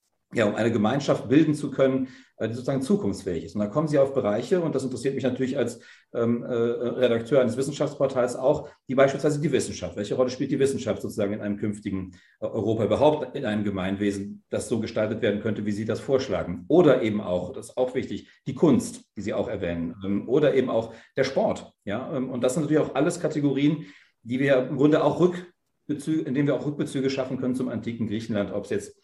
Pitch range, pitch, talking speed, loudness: 105-145 Hz, 130 Hz, 205 wpm, -25 LUFS